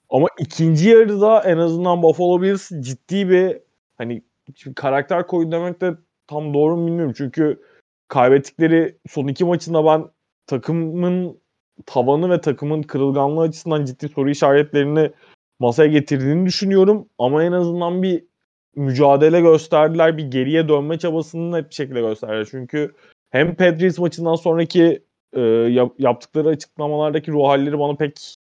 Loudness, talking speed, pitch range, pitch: -18 LUFS, 135 wpm, 140-170 Hz, 155 Hz